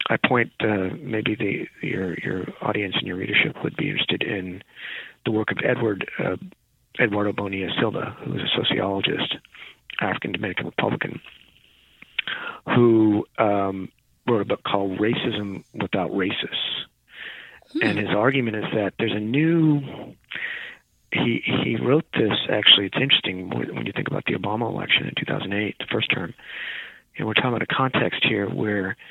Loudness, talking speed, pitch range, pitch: -23 LUFS, 155 wpm, 95-115 Hz, 105 Hz